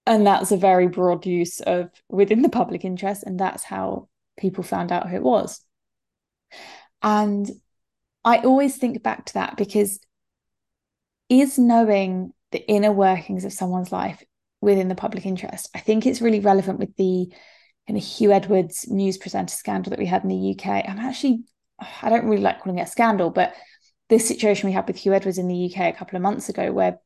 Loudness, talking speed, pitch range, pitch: -21 LUFS, 195 wpm, 185-225 Hz, 200 Hz